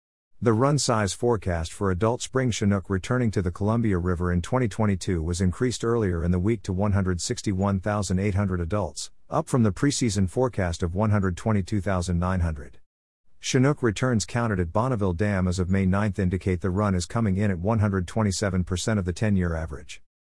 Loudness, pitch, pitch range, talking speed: -25 LUFS, 100 Hz, 90-110 Hz, 160 wpm